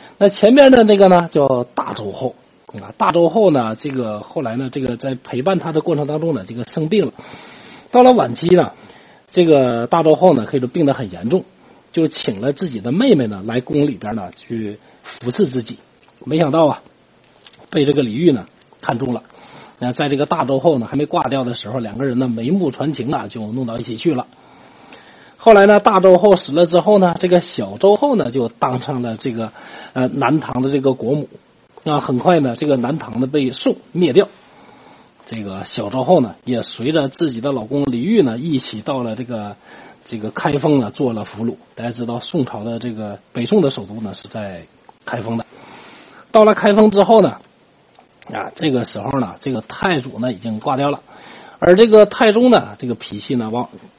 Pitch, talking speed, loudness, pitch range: 140 Hz, 280 characters per minute, -16 LUFS, 120-180 Hz